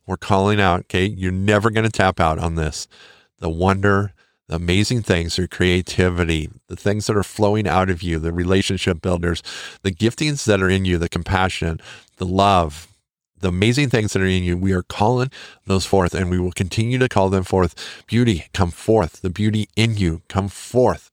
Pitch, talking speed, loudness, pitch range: 95 Hz, 195 wpm, -19 LUFS, 90-105 Hz